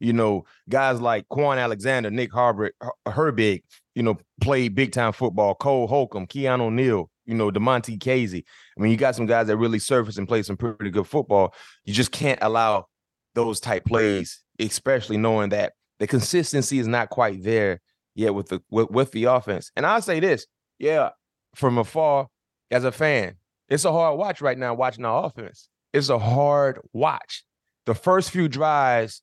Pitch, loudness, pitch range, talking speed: 120 Hz, -23 LUFS, 110-135 Hz, 180 wpm